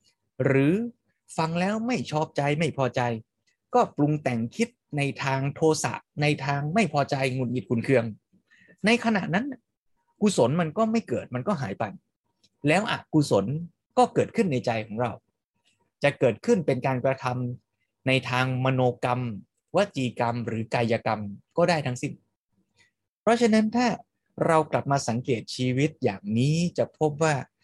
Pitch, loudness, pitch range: 140 Hz, -26 LUFS, 125-175 Hz